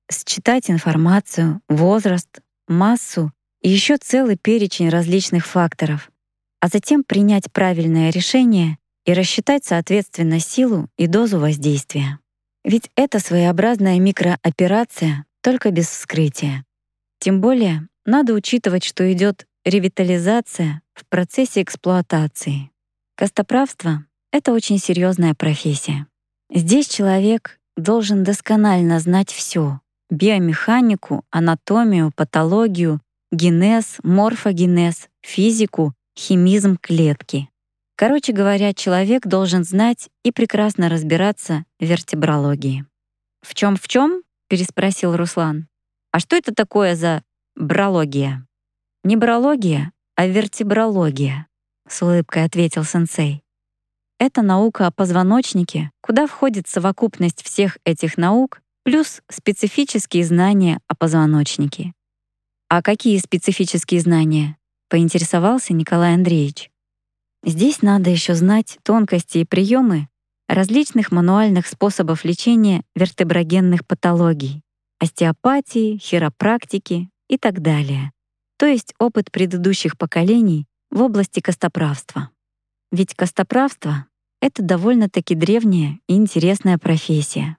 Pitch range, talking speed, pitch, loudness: 160-205 Hz, 100 wpm, 180 Hz, -17 LUFS